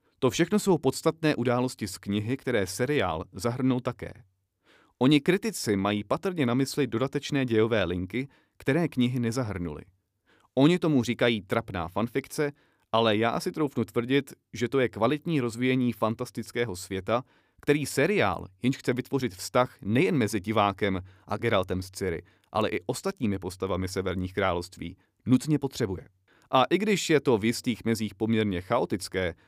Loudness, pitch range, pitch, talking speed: -27 LUFS, 100-135 Hz, 120 Hz, 145 wpm